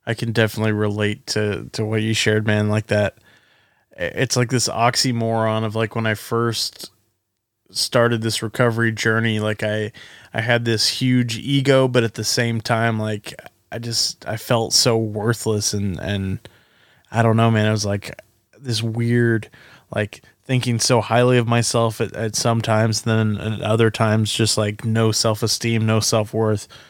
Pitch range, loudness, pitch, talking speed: 110-115 Hz, -20 LUFS, 115 Hz, 165 wpm